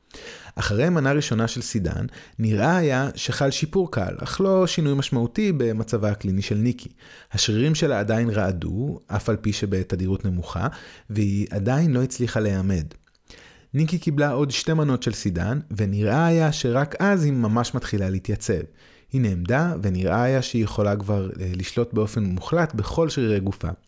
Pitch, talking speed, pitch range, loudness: 115 Hz, 150 wpm, 100-140 Hz, -23 LUFS